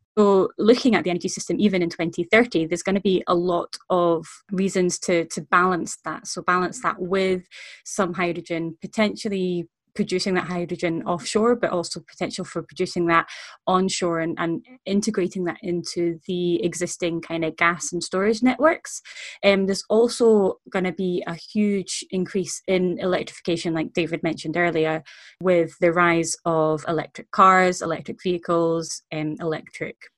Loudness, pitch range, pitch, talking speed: -23 LUFS, 170-190 Hz, 180 Hz, 155 wpm